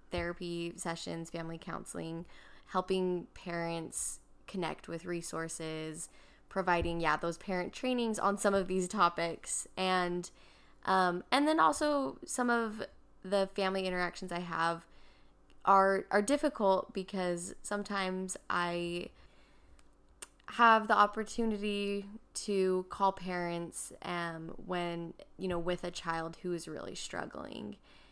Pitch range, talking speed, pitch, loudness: 170-200 Hz, 115 wpm, 180 Hz, -34 LUFS